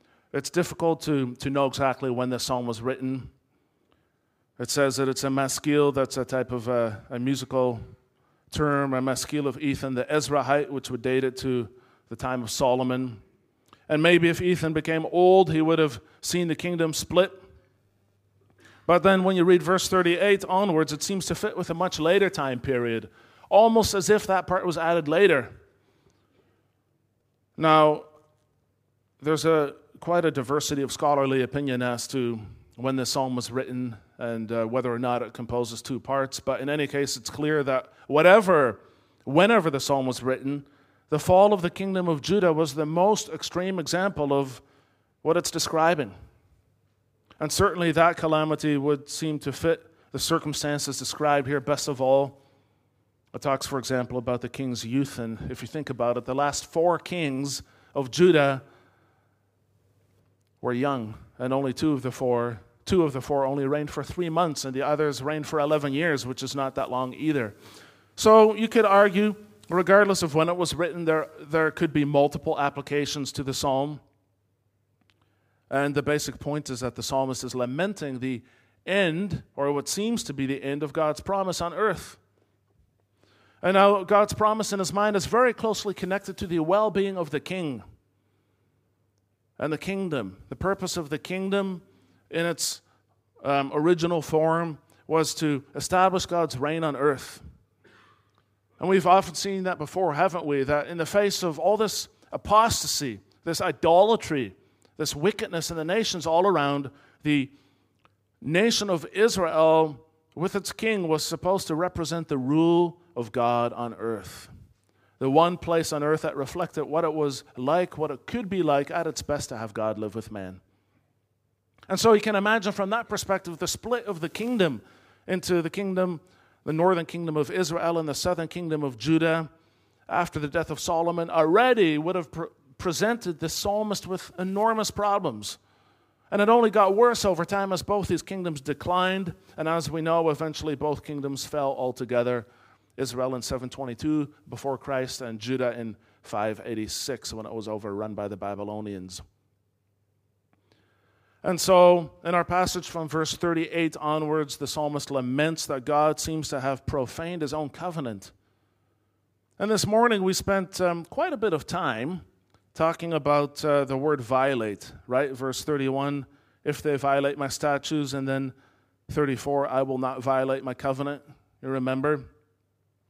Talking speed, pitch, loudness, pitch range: 165 wpm, 145 Hz, -25 LUFS, 125-170 Hz